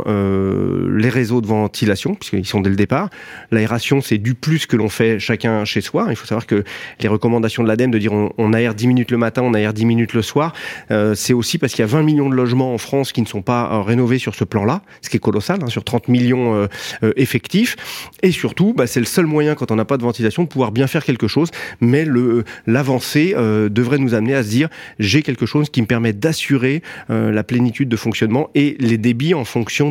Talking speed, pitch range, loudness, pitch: 245 wpm, 110-135 Hz, -17 LUFS, 120 Hz